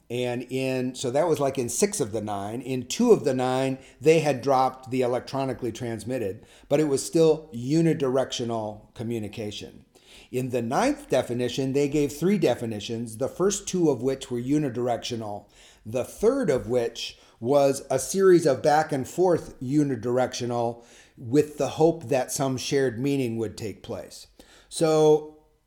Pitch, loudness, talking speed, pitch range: 130 Hz, -25 LUFS, 155 wpm, 120-150 Hz